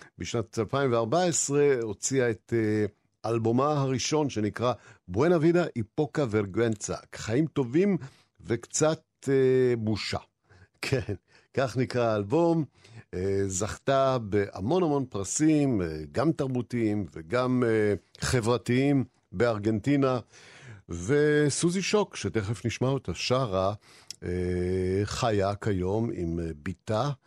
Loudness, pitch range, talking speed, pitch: -27 LUFS, 105-135 Hz, 100 wpm, 115 Hz